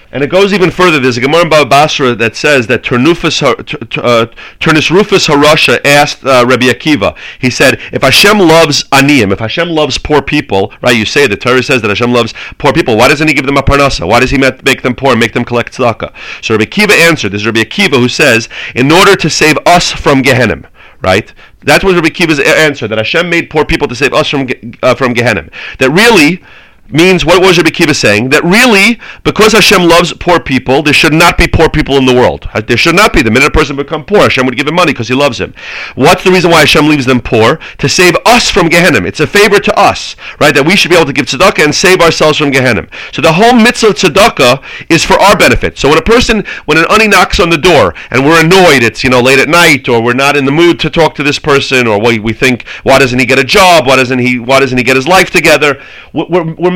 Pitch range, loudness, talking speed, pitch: 125-170 Hz, -6 LUFS, 250 wpm, 145 Hz